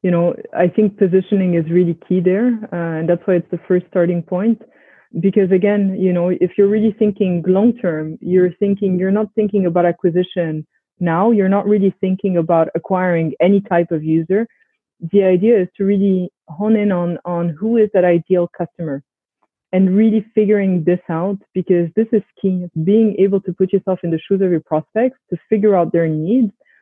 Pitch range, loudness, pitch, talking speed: 175-205 Hz, -16 LUFS, 185 Hz, 190 wpm